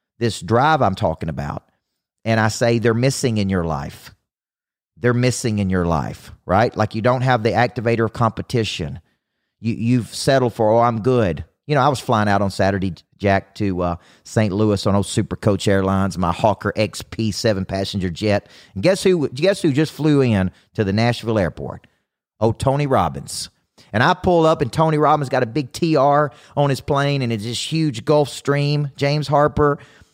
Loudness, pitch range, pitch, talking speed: -19 LUFS, 100-140 Hz, 115 Hz, 185 wpm